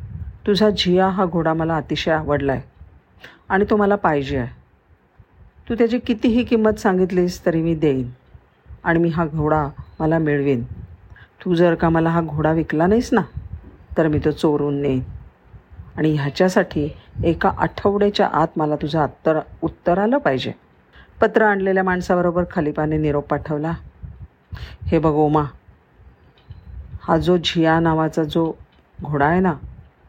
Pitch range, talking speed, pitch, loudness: 145-185 Hz, 140 wpm, 160 Hz, -19 LUFS